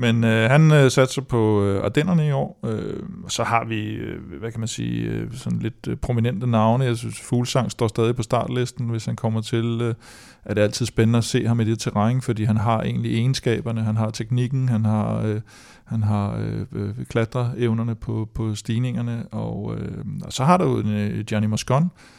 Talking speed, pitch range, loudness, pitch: 200 wpm, 110-125 Hz, -22 LUFS, 115 Hz